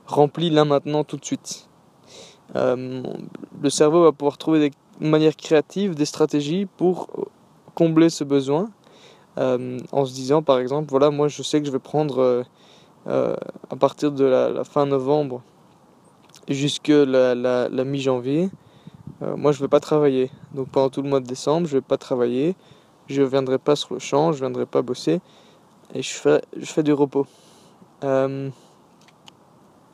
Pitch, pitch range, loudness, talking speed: 145 Hz, 135-155 Hz, -21 LUFS, 175 wpm